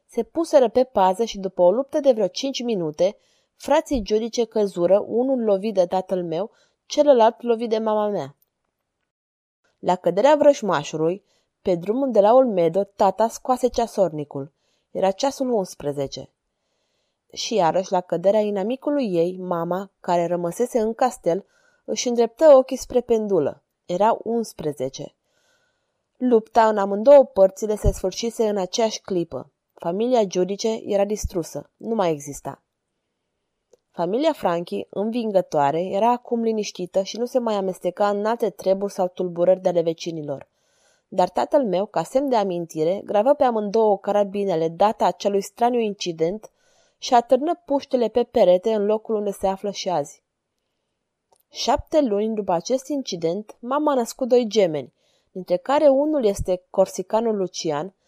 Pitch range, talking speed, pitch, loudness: 180-240 Hz, 140 wpm, 205 Hz, -21 LUFS